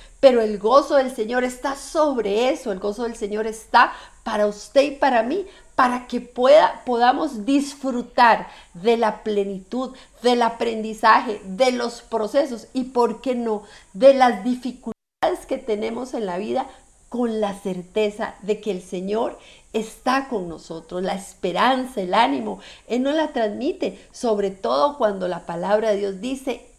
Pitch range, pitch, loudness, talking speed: 210-260 Hz, 235 Hz, -21 LUFS, 155 wpm